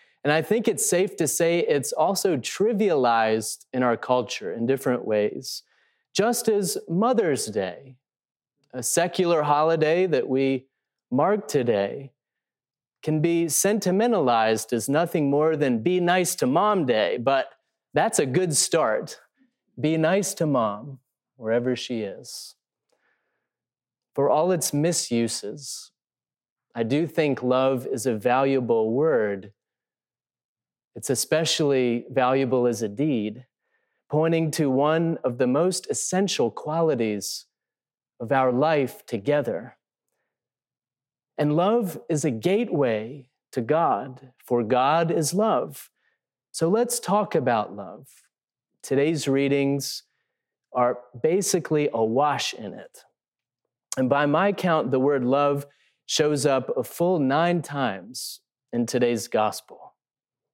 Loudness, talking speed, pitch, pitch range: -23 LUFS, 120 wpm, 145 Hz, 125-170 Hz